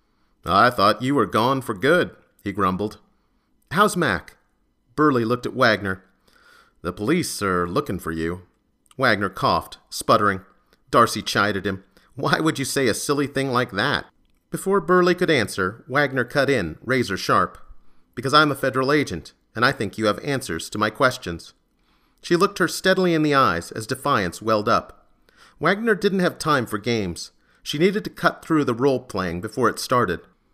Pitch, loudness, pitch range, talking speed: 125 Hz, -21 LUFS, 100-150 Hz, 170 wpm